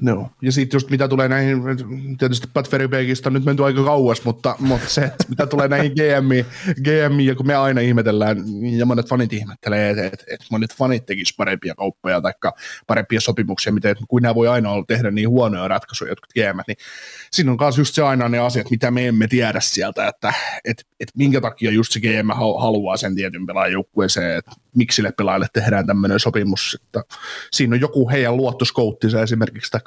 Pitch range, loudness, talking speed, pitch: 110-135 Hz, -19 LUFS, 195 wpm, 120 Hz